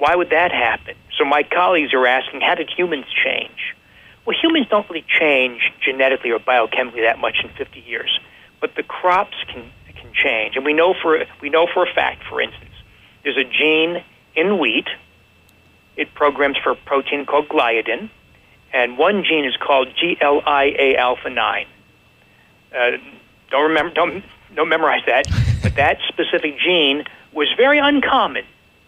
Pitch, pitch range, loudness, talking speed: 145 Hz, 130-180 Hz, -17 LUFS, 150 wpm